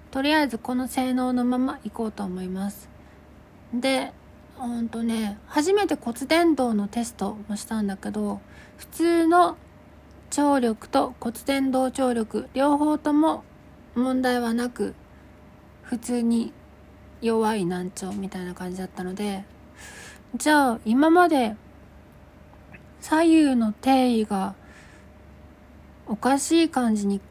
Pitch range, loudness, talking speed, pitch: 195-265 Hz, -24 LUFS, 220 characters per minute, 235 Hz